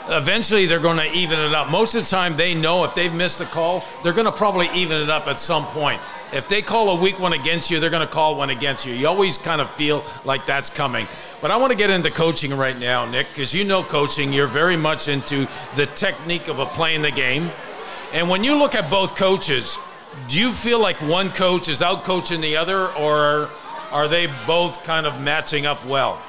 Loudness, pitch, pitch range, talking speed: -19 LUFS, 165 Hz, 150-185 Hz, 235 wpm